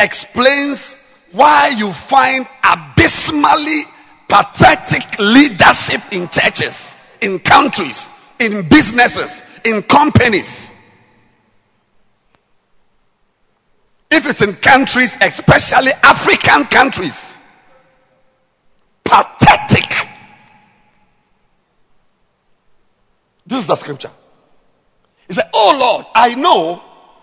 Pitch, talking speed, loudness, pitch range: 260 Hz, 75 wpm, -11 LUFS, 220-280 Hz